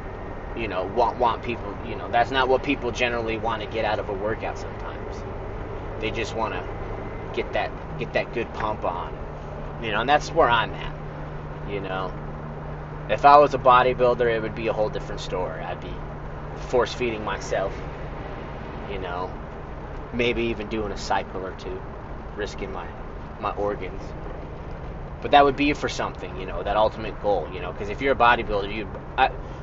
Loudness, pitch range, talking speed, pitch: -25 LUFS, 80-115 Hz, 180 wpm, 100 Hz